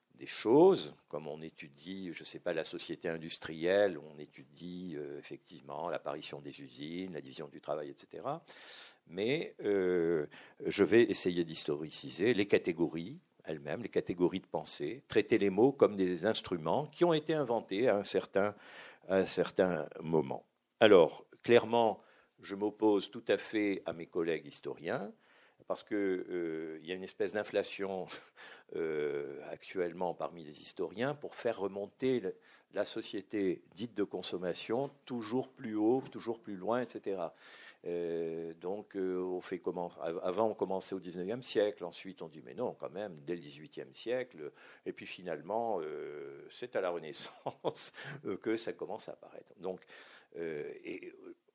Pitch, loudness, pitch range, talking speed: 100 Hz, -35 LUFS, 90-130 Hz, 155 wpm